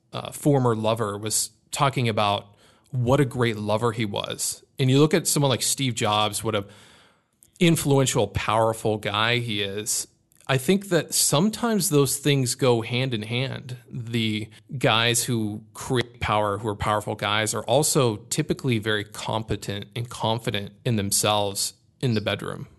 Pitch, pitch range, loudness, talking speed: 115 Hz, 105-135 Hz, -23 LUFS, 155 wpm